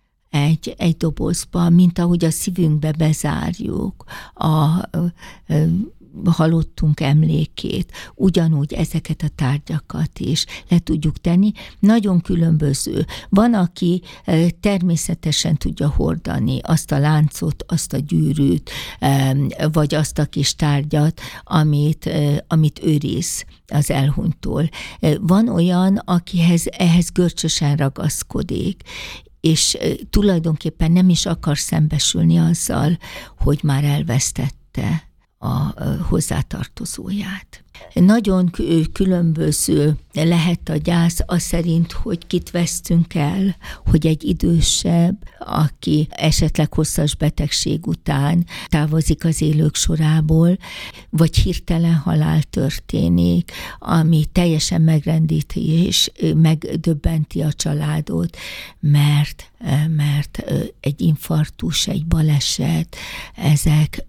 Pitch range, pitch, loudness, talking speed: 150-170 Hz, 160 Hz, -18 LUFS, 100 wpm